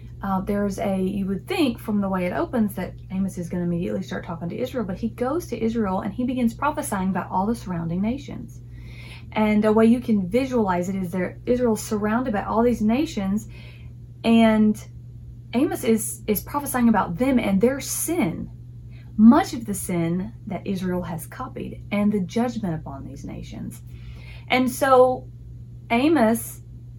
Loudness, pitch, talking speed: -23 LUFS, 195 Hz, 170 wpm